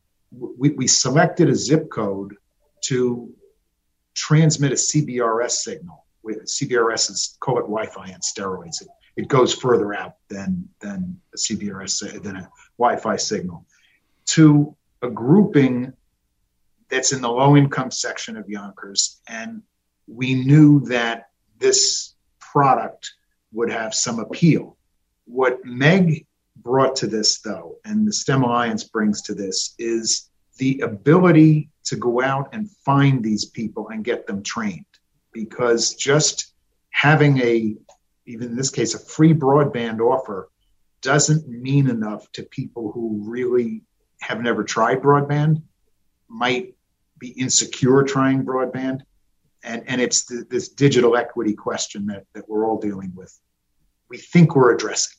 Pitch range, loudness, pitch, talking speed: 110-150 Hz, -19 LUFS, 130 Hz, 135 wpm